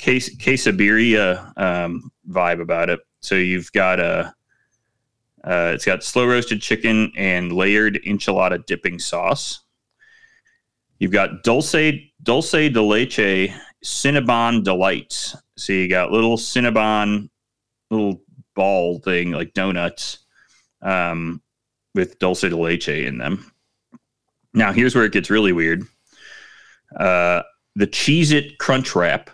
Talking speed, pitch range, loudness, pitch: 120 wpm, 95-125 Hz, -19 LUFS, 105 Hz